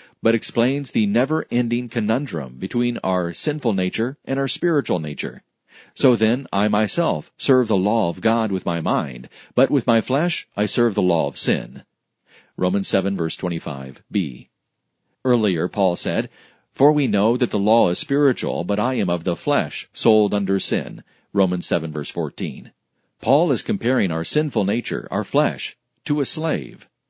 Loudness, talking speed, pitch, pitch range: -21 LUFS, 165 wpm, 115 Hz, 95-135 Hz